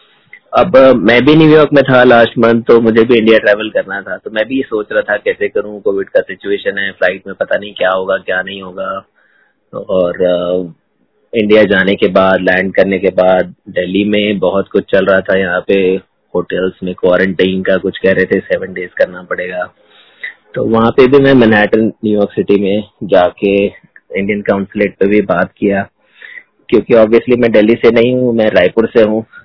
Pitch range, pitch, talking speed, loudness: 95-120 Hz, 105 Hz, 190 wpm, -11 LUFS